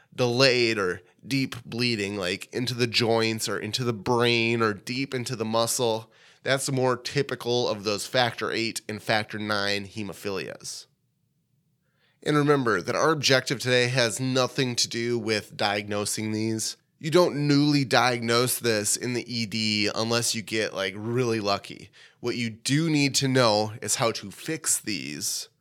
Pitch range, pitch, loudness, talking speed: 110-135 Hz, 120 Hz, -25 LUFS, 155 wpm